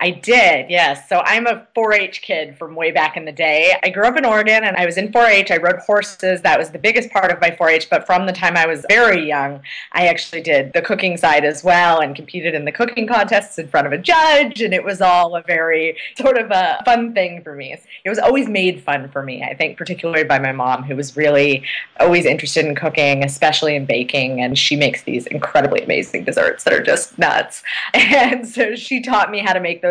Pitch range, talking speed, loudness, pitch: 155-220 Hz, 245 wpm, -15 LUFS, 175 Hz